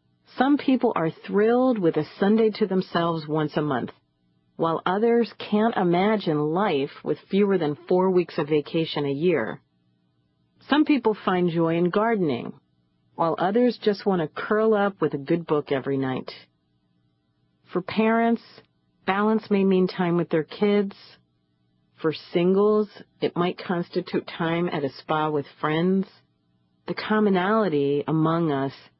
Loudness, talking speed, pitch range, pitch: -24 LUFS, 145 wpm, 140-205 Hz, 170 Hz